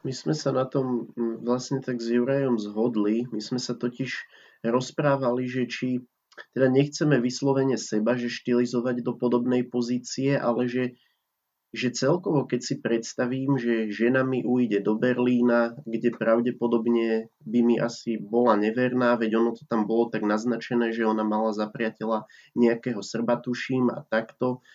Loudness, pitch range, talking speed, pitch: -26 LUFS, 115-125 Hz, 150 wpm, 120 Hz